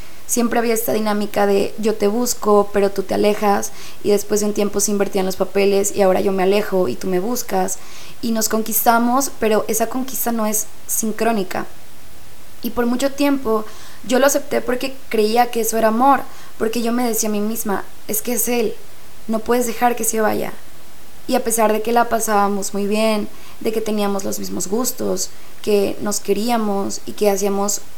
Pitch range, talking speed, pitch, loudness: 200-235 Hz, 195 wpm, 215 Hz, -19 LUFS